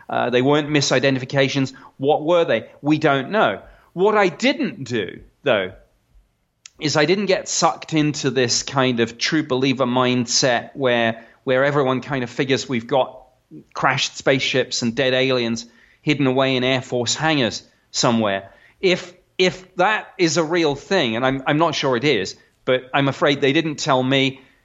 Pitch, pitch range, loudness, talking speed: 135 Hz, 130-155 Hz, -19 LUFS, 165 wpm